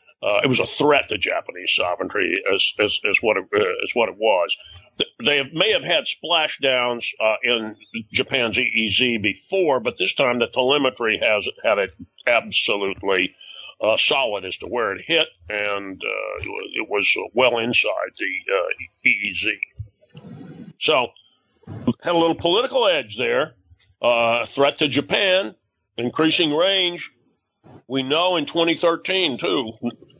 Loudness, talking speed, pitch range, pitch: -20 LUFS, 145 wpm, 115-190 Hz, 140 Hz